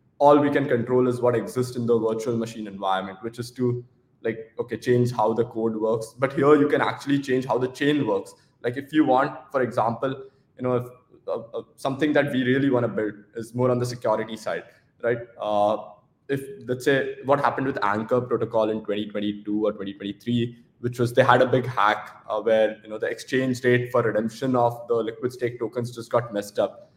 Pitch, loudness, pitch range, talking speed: 120 Hz, -24 LUFS, 110-130 Hz, 210 wpm